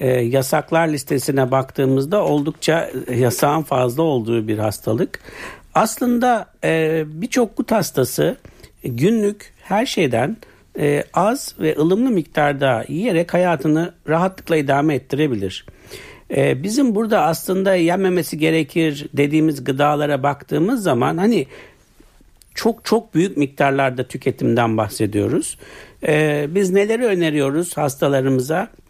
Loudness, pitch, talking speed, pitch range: -18 LUFS, 155 Hz, 95 wpm, 135-180 Hz